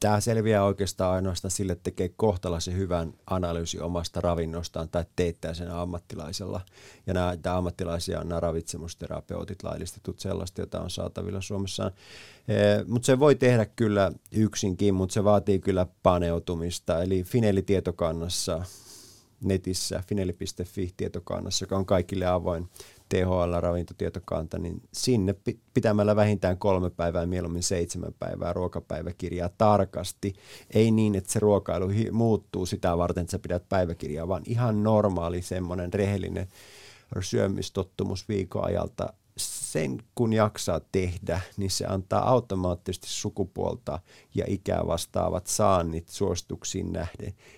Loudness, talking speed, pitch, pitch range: -28 LUFS, 120 wpm, 95 Hz, 90-105 Hz